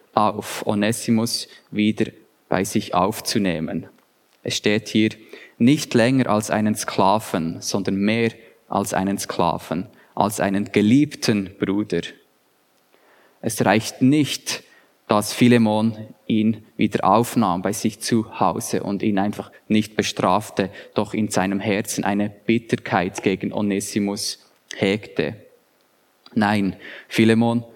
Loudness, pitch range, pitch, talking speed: -21 LUFS, 100-115 Hz, 110 Hz, 110 wpm